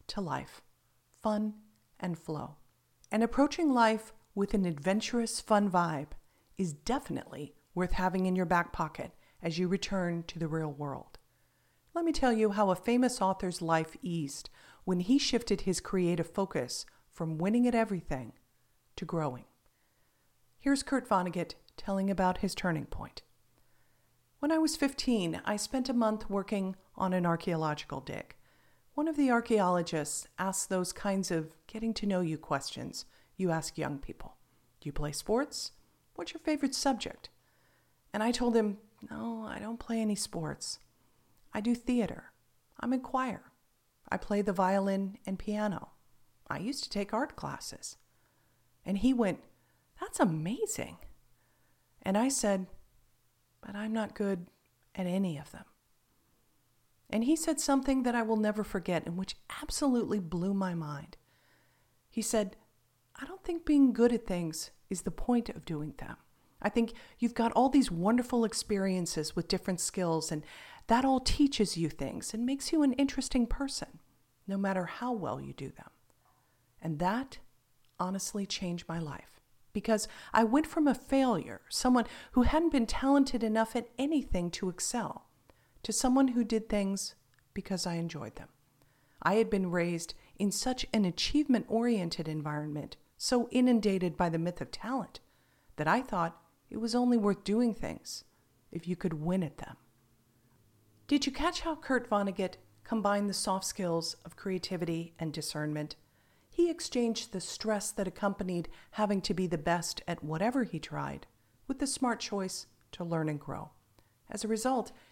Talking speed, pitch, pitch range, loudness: 160 wpm, 200 Hz, 170-235 Hz, -32 LUFS